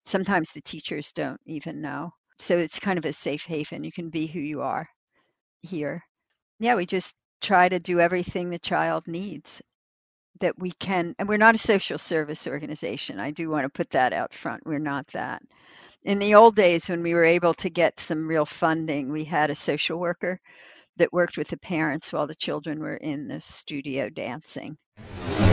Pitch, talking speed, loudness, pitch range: 165 Hz, 195 wpm, -25 LUFS, 150-180 Hz